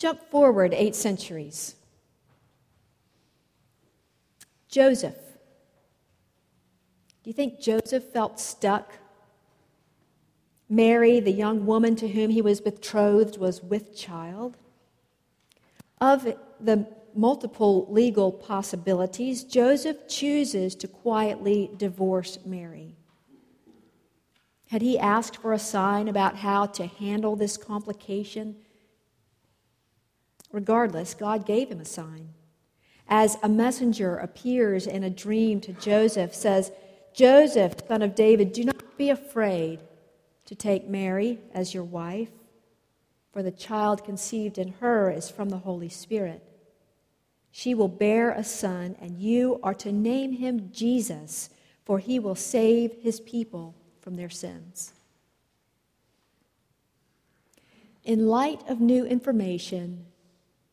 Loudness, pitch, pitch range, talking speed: -25 LUFS, 205 Hz, 180-225 Hz, 110 wpm